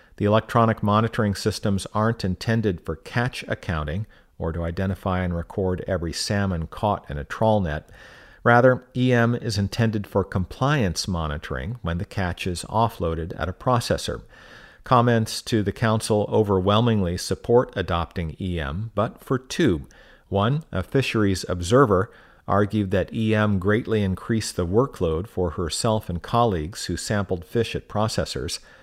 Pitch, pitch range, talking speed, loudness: 100 Hz, 90-115 Hz, 140 wpm, -23 LUFS